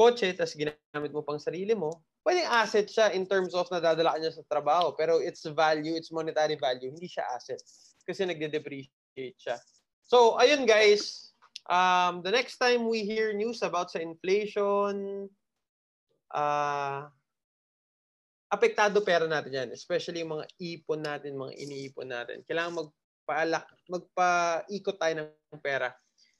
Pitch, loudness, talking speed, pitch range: 170 Hz, -28 LUFS, 140 wpm, 155-200 Hz